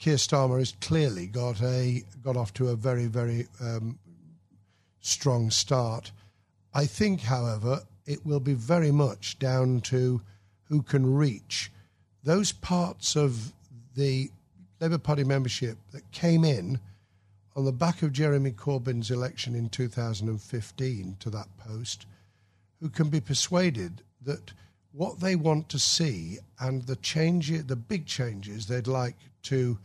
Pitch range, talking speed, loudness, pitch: 105-145 Hz, 140 wpm, -28 LUFS, 125 Hz